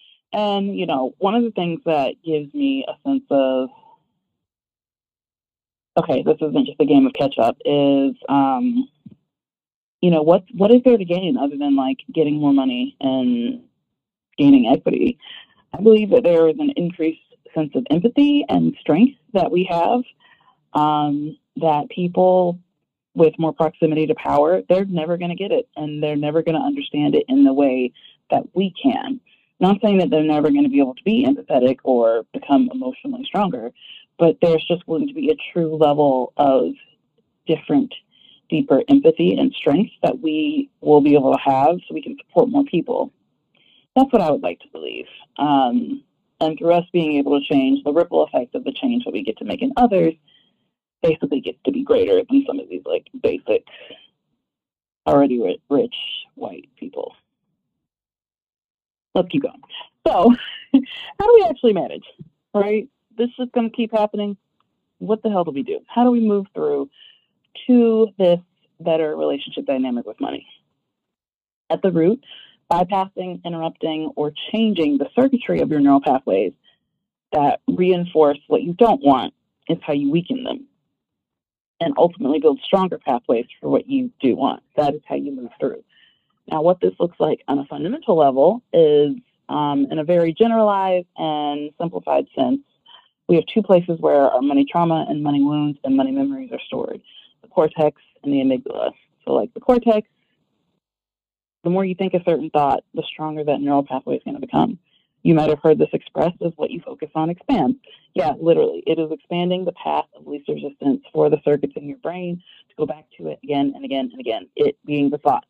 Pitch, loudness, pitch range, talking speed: 175 Hz, -19 LUFS, 150-250 Hz, 180 wpm